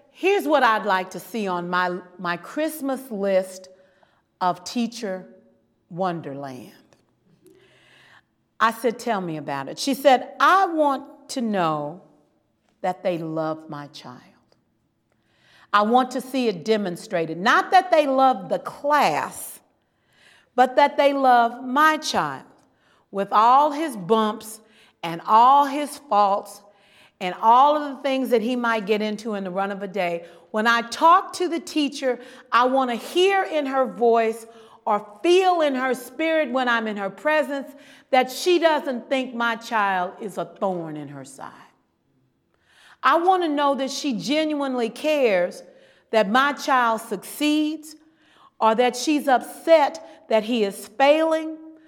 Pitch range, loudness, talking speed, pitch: 195-285 Hz, -21 LUFS, 150 wpm, 235 Hz